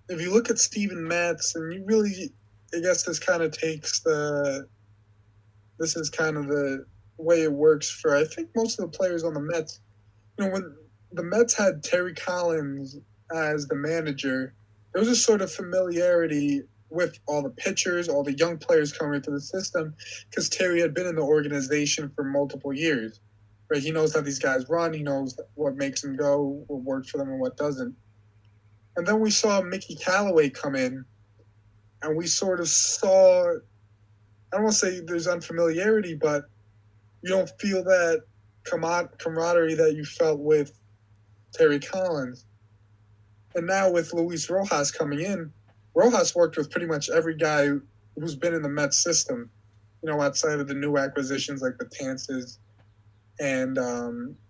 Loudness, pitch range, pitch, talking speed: -25 LUFS, 125-175 Hz, 150 Hz, 175 wpm